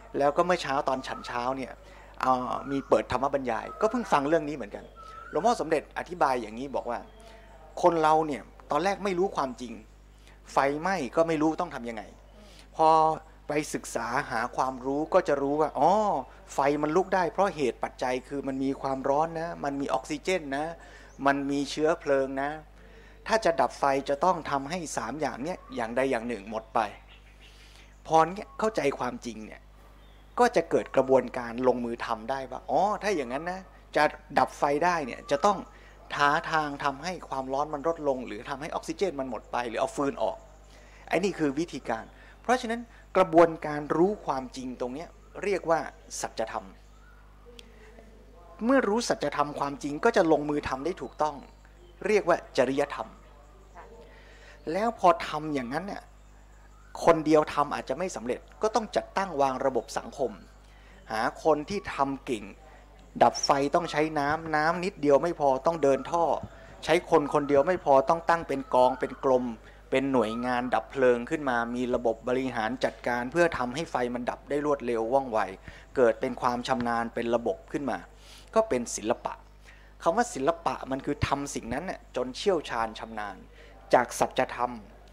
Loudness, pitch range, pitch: -28 LUFS, 130-170 Hz, 145 Hz